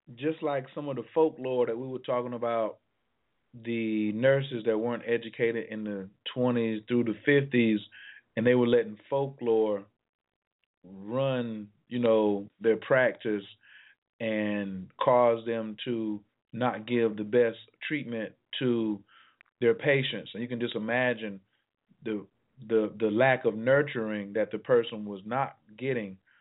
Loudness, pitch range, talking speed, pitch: -29 LUFS, 105-125 Hz, 140 wpm, 115 Hz